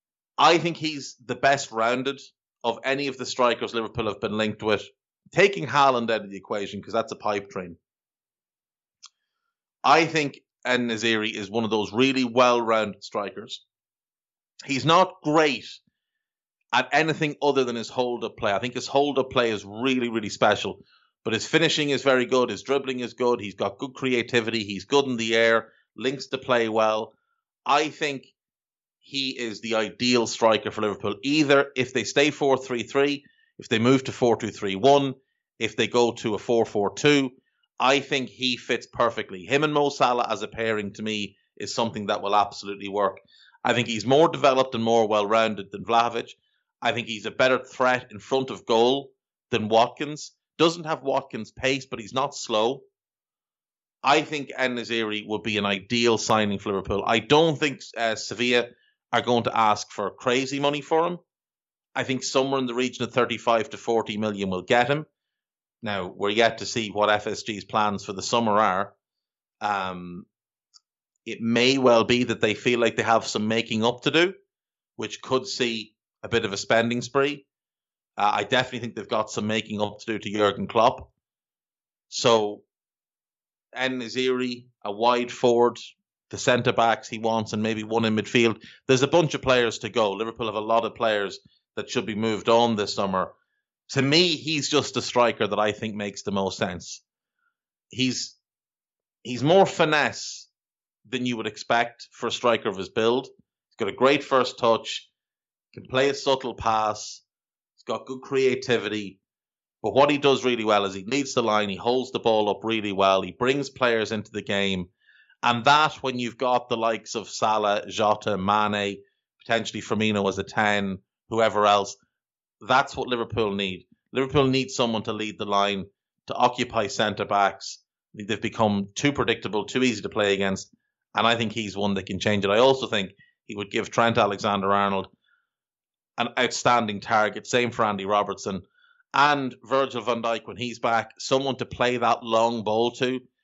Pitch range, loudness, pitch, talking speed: 105-130 Hz, -24 LUFS, 120 Hz, 185 wpm